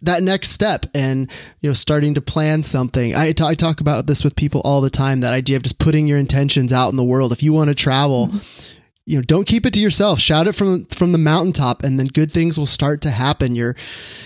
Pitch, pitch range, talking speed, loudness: 145 Hz, 135-155 Hz, 240 wpm, -15 LUFS